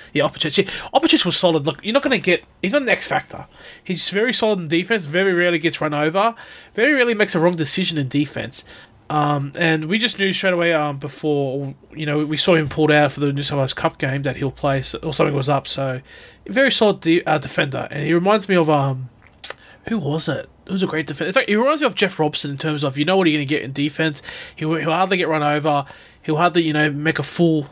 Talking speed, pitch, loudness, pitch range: 250 wpm, 160 Hz, -19 LUFS, 145-185 Hz